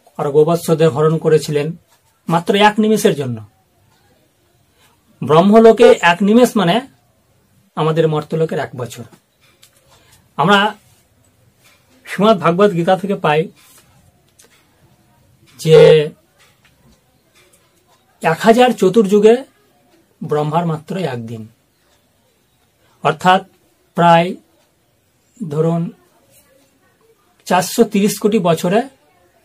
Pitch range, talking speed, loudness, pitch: 150-215 Hz, 70 wpm, -13 LUFS, 170 Hz